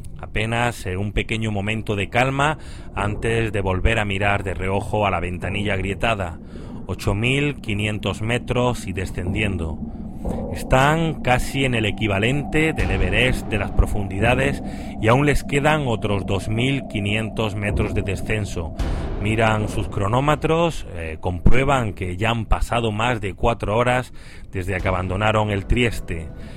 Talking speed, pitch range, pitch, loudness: 130 wpm, 95-120 Hz, 105 Hz, -22 LUFS